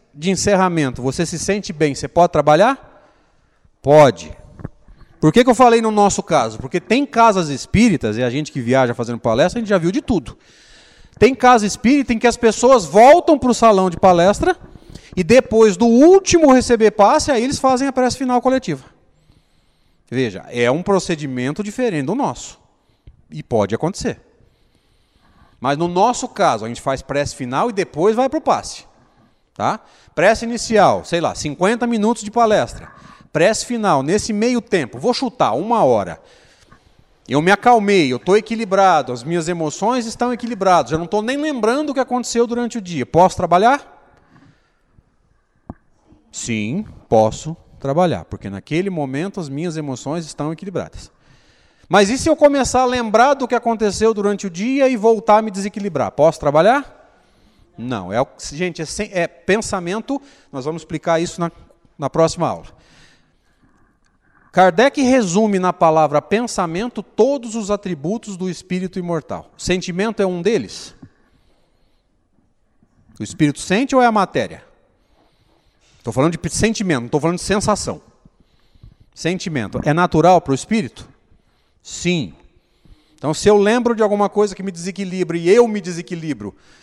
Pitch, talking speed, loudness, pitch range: 195 Hz, 155 wpm, -17 LUFS, 155-230 Hz